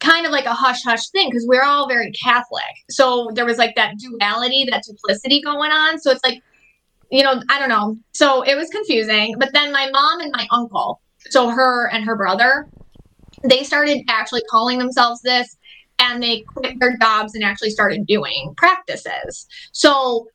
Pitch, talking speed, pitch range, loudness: 250 Hz, 185 wpm, 230-275 Hz, -16 LUFS